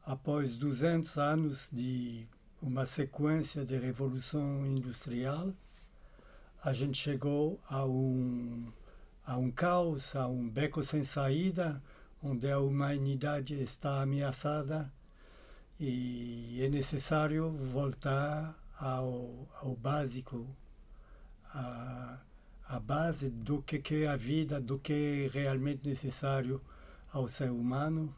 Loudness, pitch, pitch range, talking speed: -36 LUFS, 140 Hz, 130-150 Hz, 105 wpm